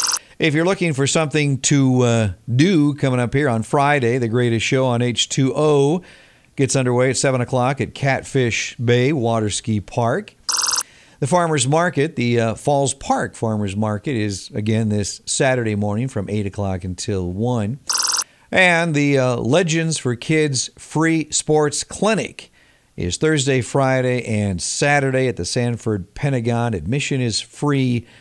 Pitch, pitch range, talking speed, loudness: 125 Hz, 110-145 Hz, 145 wpm, -19 LUFS